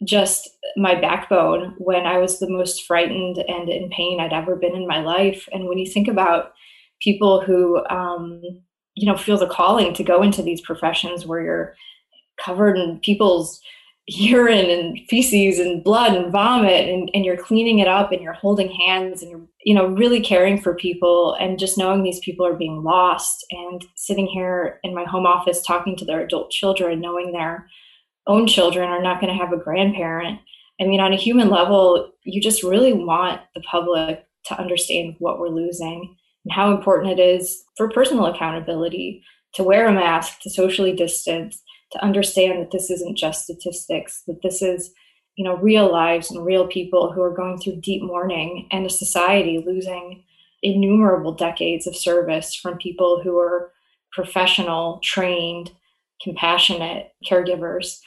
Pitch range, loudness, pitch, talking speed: 175-195 Hz, -19 LUFS, 180 Hz, 175 wpm